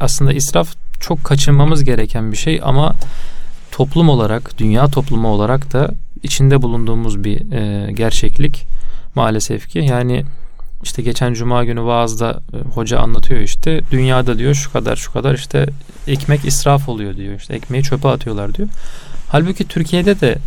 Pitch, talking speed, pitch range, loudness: 130 Hz, 140 wpm, 115-145 Hz, -16 LUFS